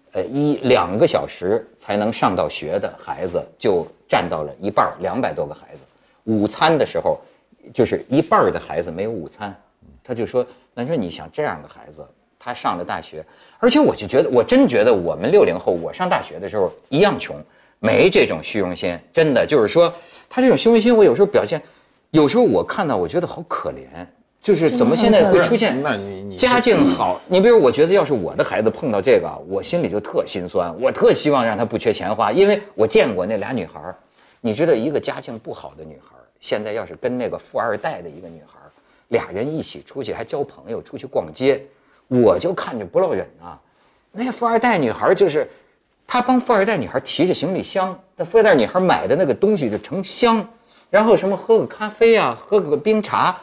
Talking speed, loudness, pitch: 305 characters per minute, -18 LUFS, 230 Hz